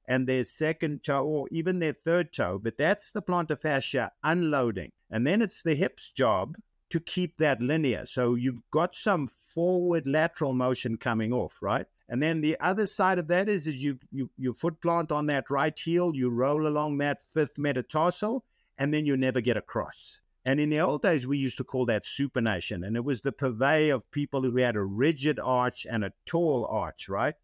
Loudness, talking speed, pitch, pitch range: -28 LUFS, 205 wpm, 145 Hz, 125-165 Hz